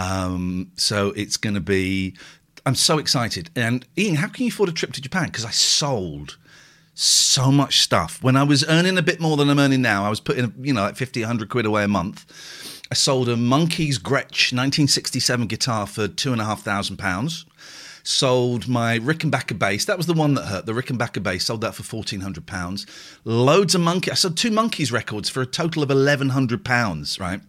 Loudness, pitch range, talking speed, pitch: -20 LUFS, 105-145 Hz, 205 wpm, 125 Hz